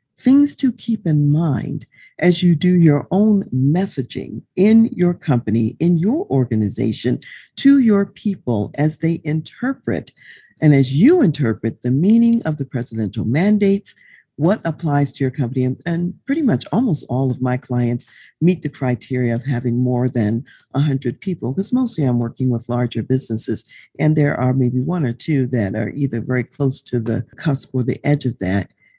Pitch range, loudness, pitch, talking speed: 125-175 Hz, -18 LUFS, 140 Hz, 170 wpm